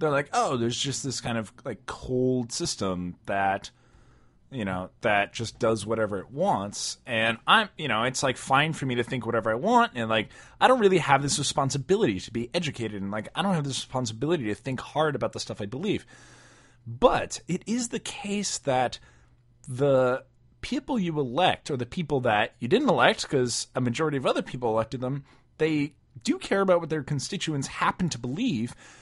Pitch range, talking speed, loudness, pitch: 115-155 Hz, 195 wpm, -27 LUFS, 130 Hz